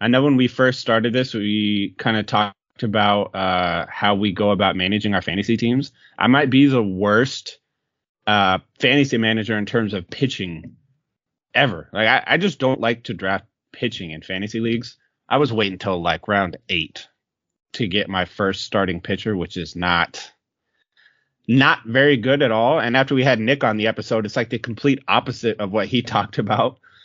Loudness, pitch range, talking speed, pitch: -19 LUFS, 100-125 Hz, 190 wpm, 110 Hz